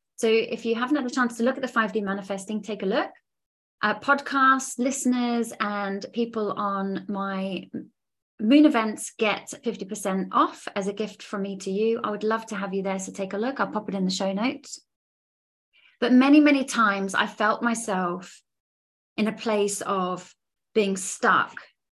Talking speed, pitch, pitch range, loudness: 185 wpm, 215 Hz, 195-245 Hz, -25 LUFS